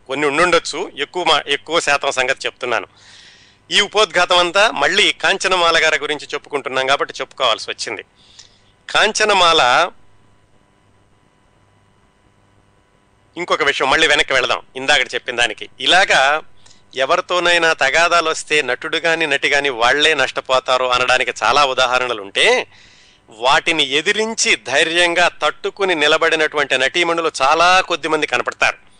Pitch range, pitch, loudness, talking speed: 125-170 Hz, 145 Hz, -15 LUFS, 105 wpm